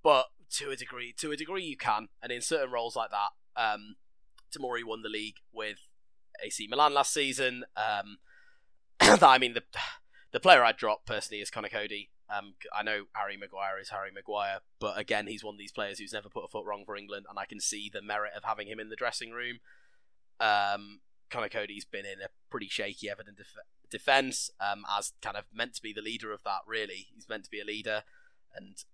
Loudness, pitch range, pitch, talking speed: -31 LUFS, 105-135 Hz, 110 Hz, 215 wpm